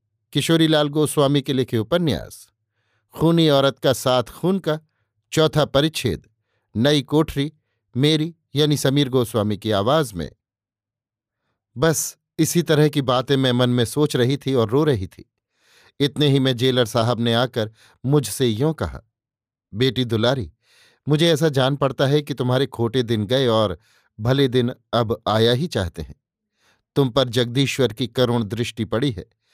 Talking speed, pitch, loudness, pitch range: 150 wpm, 130 Hz, -20 LUFS, 115-145 Hz